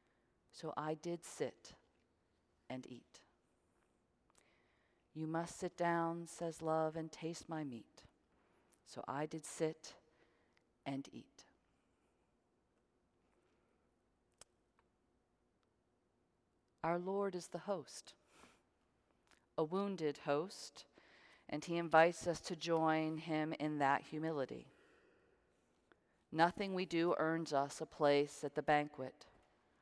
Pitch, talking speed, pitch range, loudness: 160 Hz, 100 wpm, 145-170 Hz, -40 LUFS